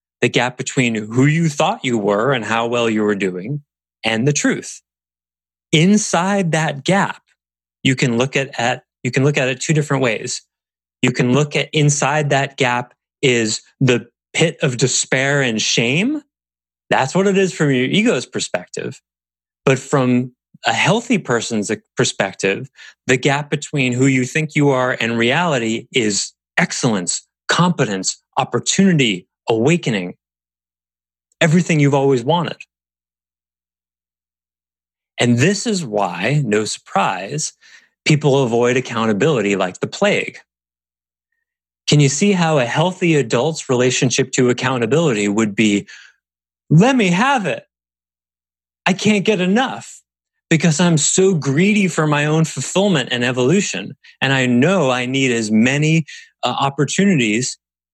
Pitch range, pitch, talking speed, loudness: 105-155 Hz, 130 Hz, 135 wpm, -17 LUFS